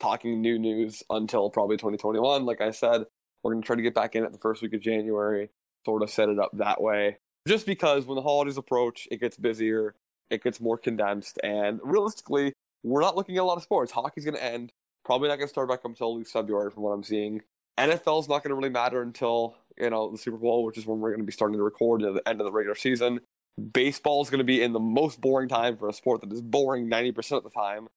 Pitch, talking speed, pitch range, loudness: 115 Hz, 245 wpm, 110-130 Hz, -27 LUFS